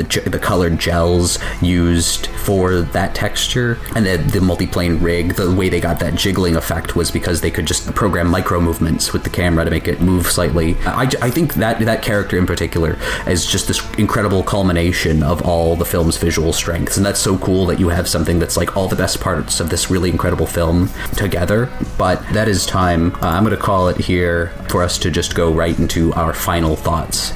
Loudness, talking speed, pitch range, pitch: -16 LUFS, 205 wpm, 85-95 Hz, 90 Hz